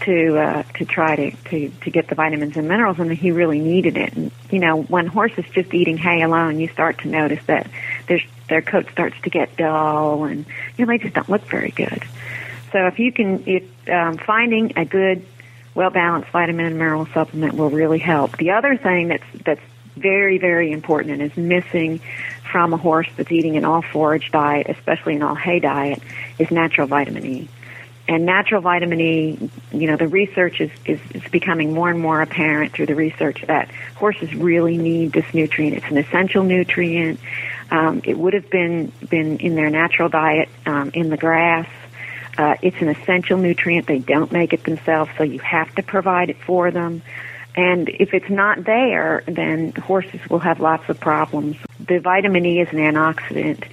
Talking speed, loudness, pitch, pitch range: 190 wpm, -18 LUFS, 165 Hz, 155-180 Hz